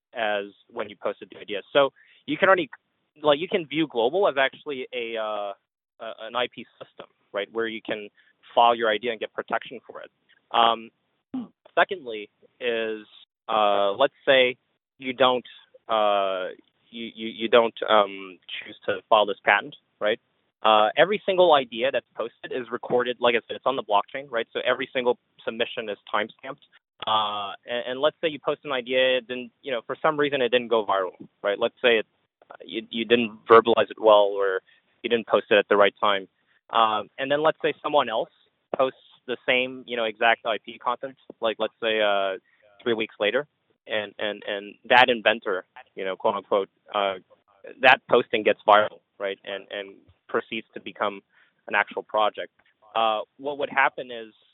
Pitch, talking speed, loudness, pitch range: 115 Hz, 185 wpm, -24 LUFS, 105-135 Hz